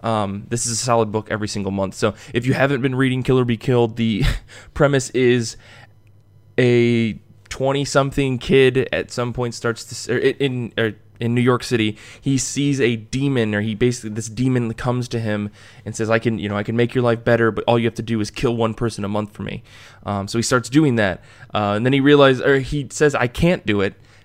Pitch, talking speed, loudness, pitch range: 115 Hz, 230 wpm, -19 LUFS, 110-125 Hz